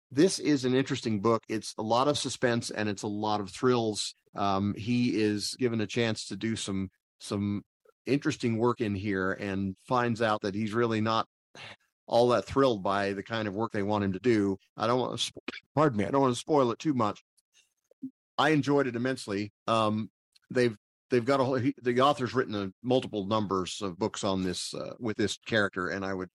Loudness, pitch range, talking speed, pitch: -29 LUFS, 100-125 Hz, 210 wpm, 110 Hz